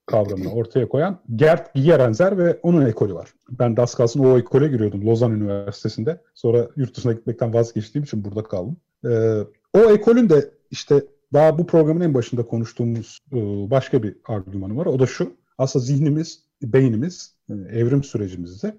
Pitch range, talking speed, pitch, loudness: 110-155 Hz, 155 wpm, 125 Hz, -20 LUFS